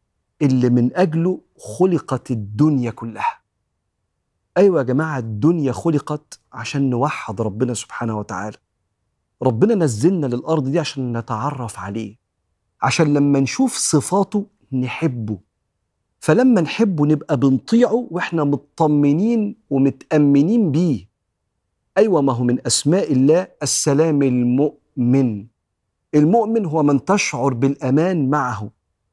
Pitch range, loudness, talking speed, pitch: 120-160 Hz, -18 LUFS, 105 wpm, 140 Hz